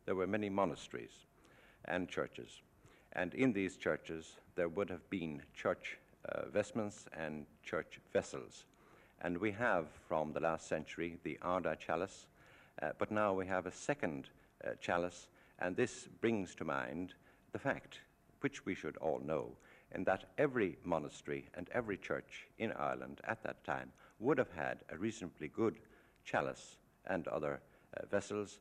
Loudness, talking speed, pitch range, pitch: -41 LUFS, 155 wpm, 80-105 Hz, 90 Hz